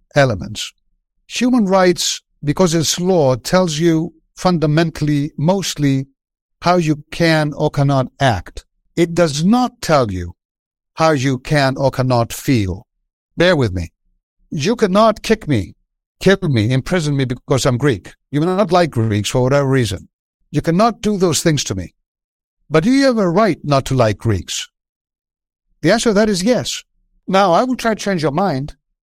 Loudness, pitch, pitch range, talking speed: -16 LUFS, 150 Hz, 130-185 Hz, 165 wpm